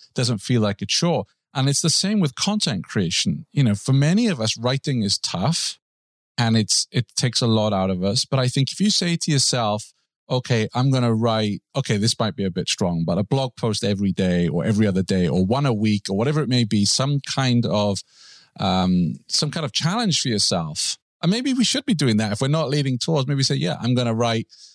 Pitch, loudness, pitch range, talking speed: 120 Hz, -21 LUFS, 105-145 Hz, 240 wpm